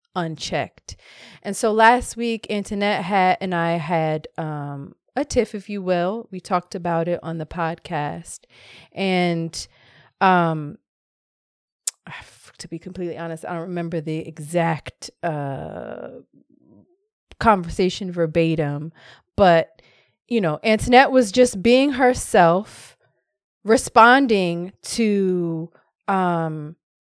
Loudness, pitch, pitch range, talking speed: -20 LUFS, 175 Hz, 165-210 Hz, 105 wpm